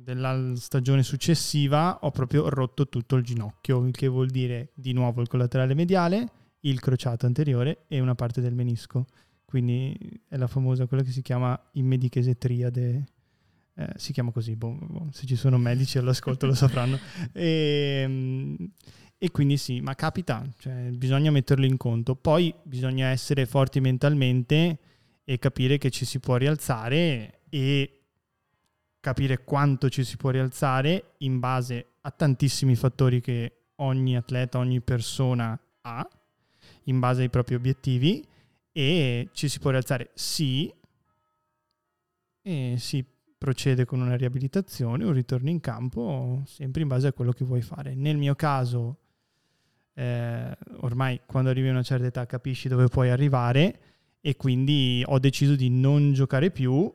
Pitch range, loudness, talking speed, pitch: 125-140 Hz, -26 LUFS, 150 wpm, 130 Hz